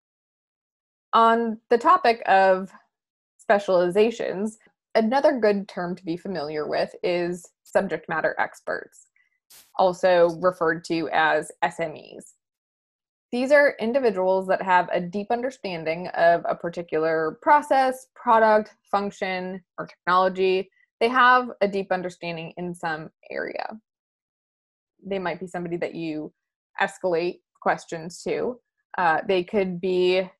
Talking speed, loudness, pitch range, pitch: 115 wpm, -23 LUFS, 175-230 Hz, 190 Hz